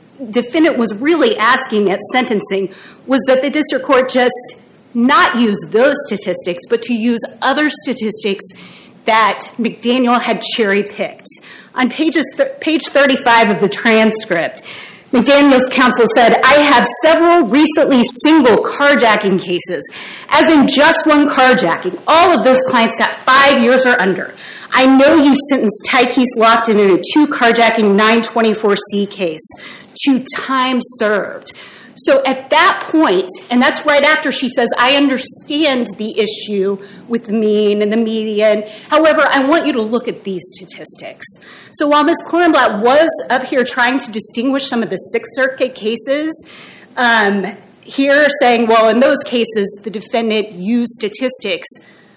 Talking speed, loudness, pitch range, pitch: 150 wpm, -12 LUFS, 215-280 Hz, 245 Hz